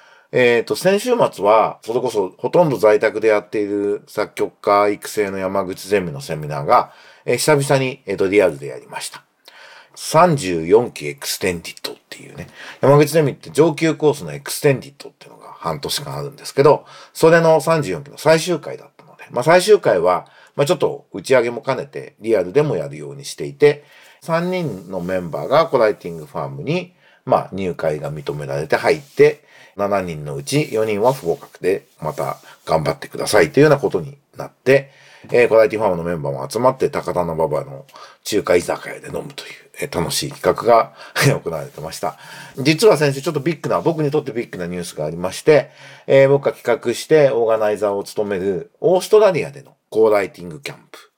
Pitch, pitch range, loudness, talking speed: 145 Hz, 105-165 Hz, -18 LUFS, 395 characters per minute